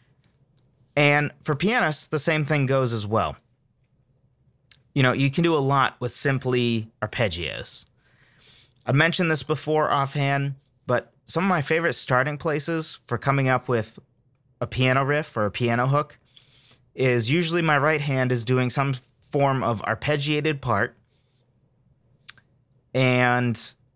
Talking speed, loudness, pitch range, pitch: 140 wpm, -23 LUFS, 125-145 Hz, 130 Hz